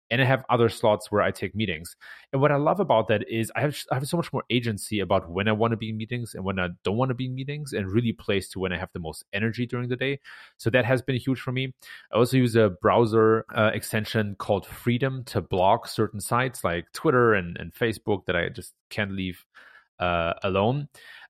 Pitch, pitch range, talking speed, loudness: 110 Hz, 100-125 Hz, 240 wpm, -25 LUFS